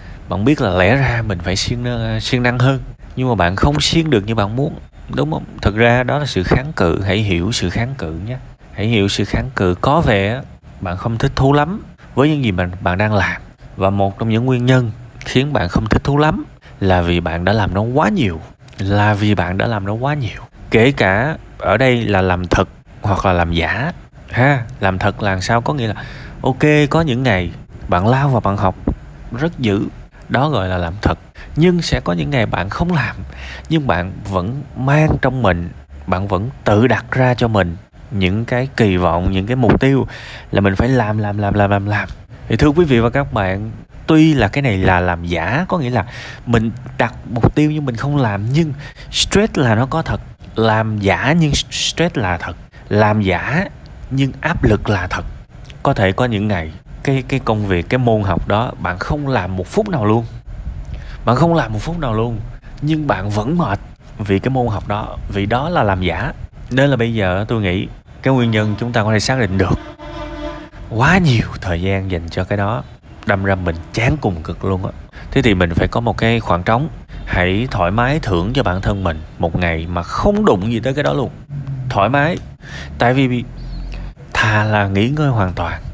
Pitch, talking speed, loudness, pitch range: 110 Hz, 215 wpm, -16 LUFS, 95-130 Hz